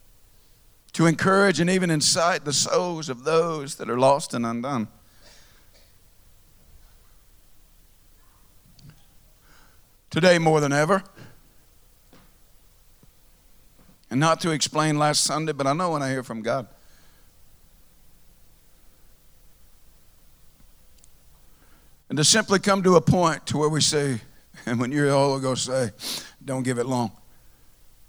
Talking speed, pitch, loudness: 115 wpm, 120 Hz, -22 LUFS